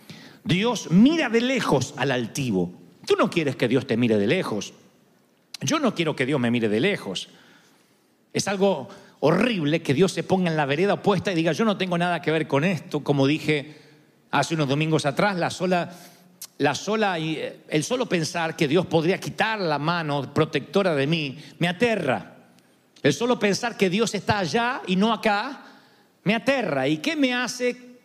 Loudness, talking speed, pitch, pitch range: -23 LUFS, 180 wpm, 175 Hz, 150-210 Hz